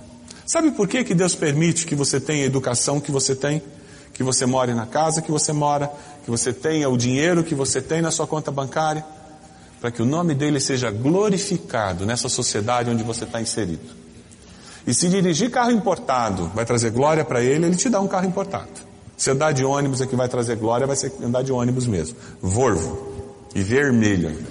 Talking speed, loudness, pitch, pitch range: 200 wpm, -21 LUFS, 140 Hz, 120-155 Hz